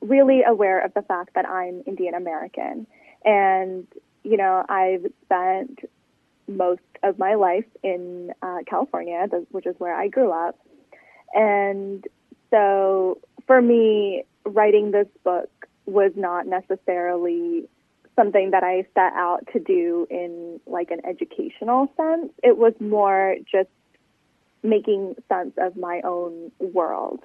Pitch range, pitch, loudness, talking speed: 185-235 Hz, 195 Hz, -22 LUFS, 130 wpm